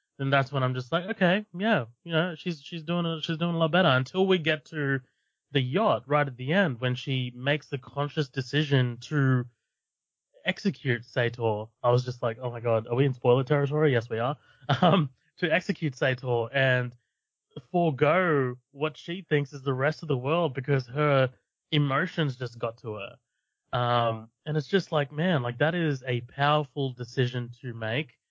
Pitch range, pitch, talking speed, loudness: 125-160 Hz, 140 Hz, 190 wpm, -27 LUFS